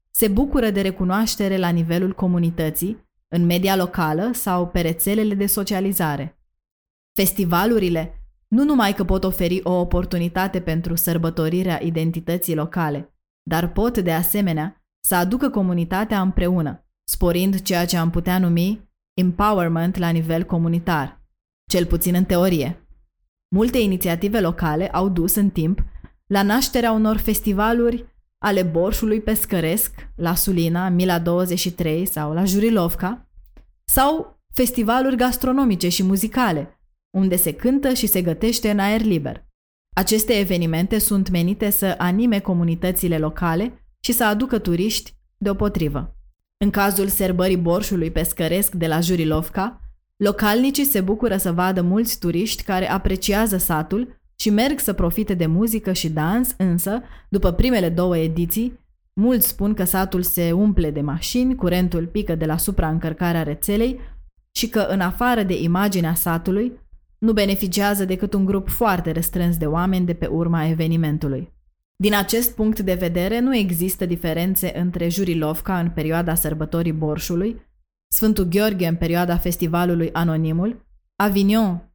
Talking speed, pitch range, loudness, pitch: 135 wpm, 170-205 Hz, -20 LUFS, 185 Hz